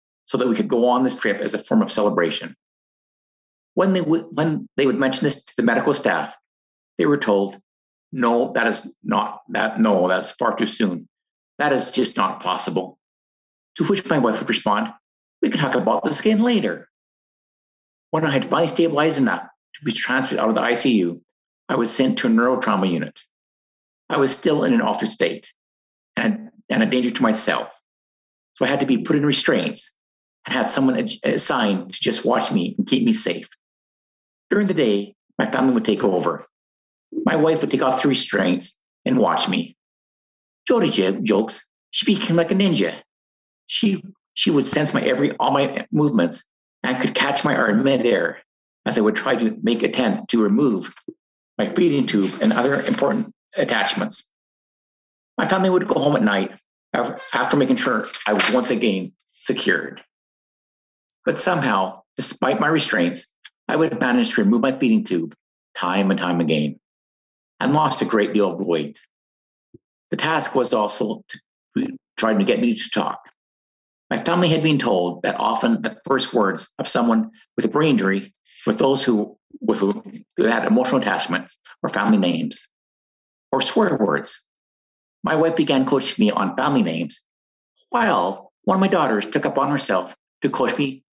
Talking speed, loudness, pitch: 175 wpm, -20 LUFS, 160 Hz